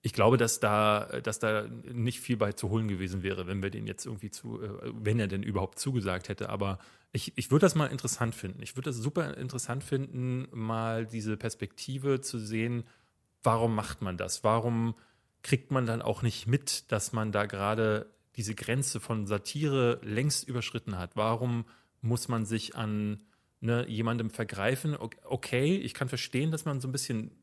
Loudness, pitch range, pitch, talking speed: -31 LUFS, 105-125 Hz, 115 Hz, 180 wpm